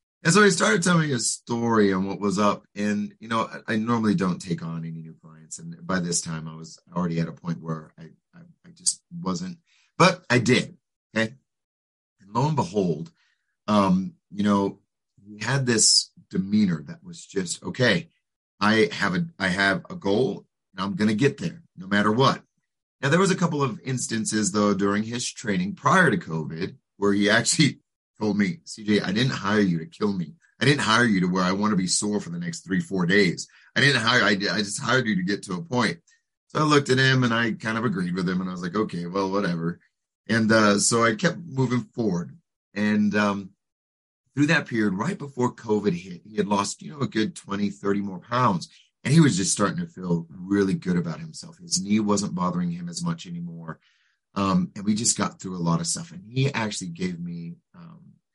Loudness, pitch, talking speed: -24 LUFS, 115 Hz, 215 wpm